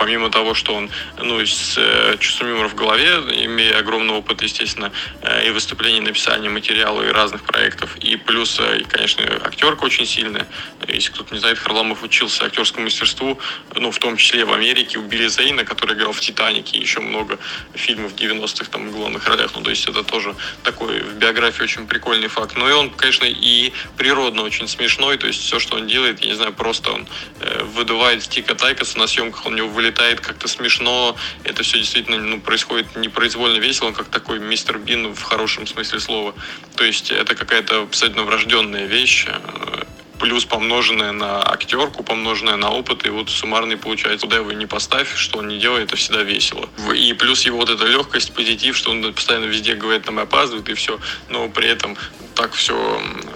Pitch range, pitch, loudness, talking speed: 110-115 Hz, 115 Hz, -16 LUFS, 190 wpm